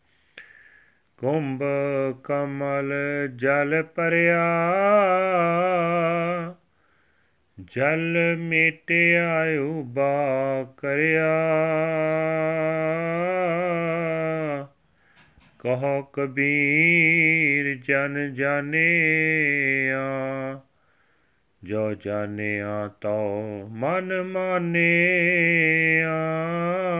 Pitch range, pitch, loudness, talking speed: 140-170 Hz, 160 Hz, -22 LUFS, 40 wpm